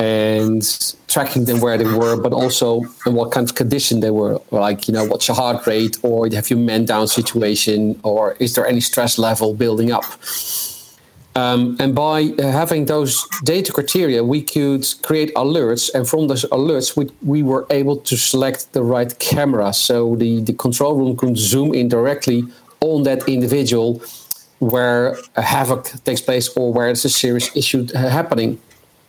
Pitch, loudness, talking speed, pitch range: 125 Hz, -17 LUFS, 175 wpm, 115-140 Hz